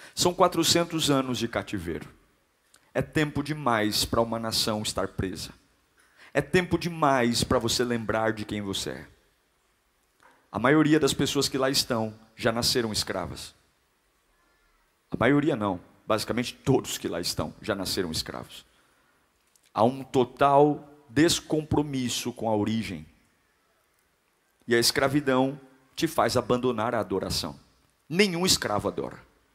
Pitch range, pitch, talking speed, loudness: 110-145 Hz, 125 Hz, 125 wpm, -26 LUFS